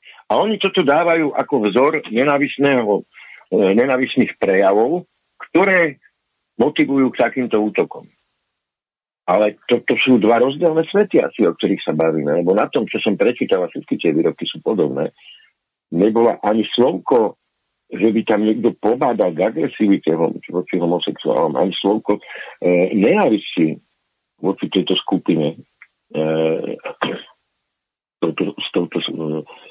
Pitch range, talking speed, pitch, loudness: 100-140 Hz, 130 wpm, 110 Hz, -17 LUFS